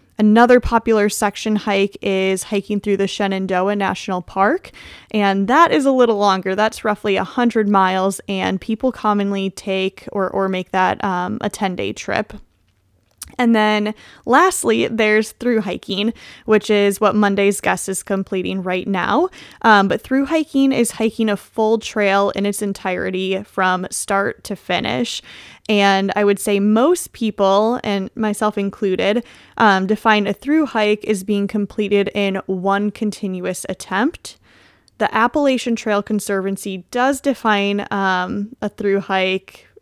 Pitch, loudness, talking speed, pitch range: 205 Hz, -18 LUFS, 145 wpm, 195-220 Hz